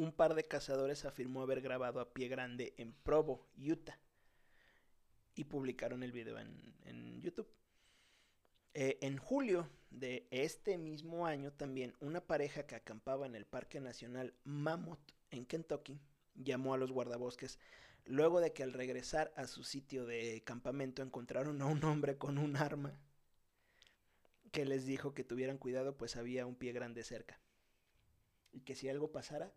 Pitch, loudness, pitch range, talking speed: 135 Hz, -42 LUFS, 125-145 Hz, 155 wpm